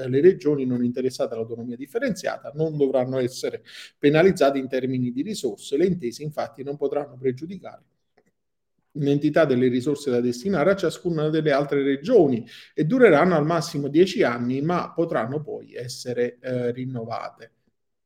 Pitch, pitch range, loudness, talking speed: 140 Hz, 125-160 Hz, -23 LUFS, 140 wpm